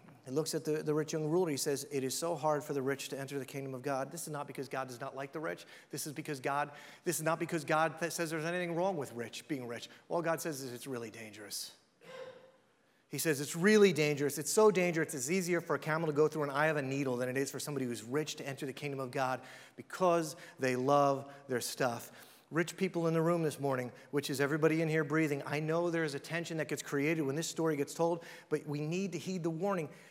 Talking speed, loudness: 255 wpm, -35 LUFS